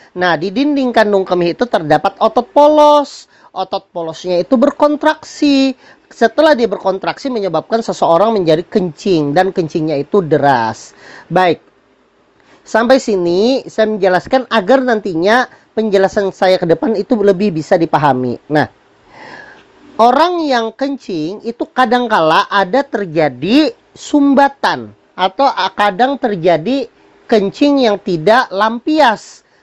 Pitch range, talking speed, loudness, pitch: 185-265 Hz, 115 wpm, -13 LUFS, 215 Hz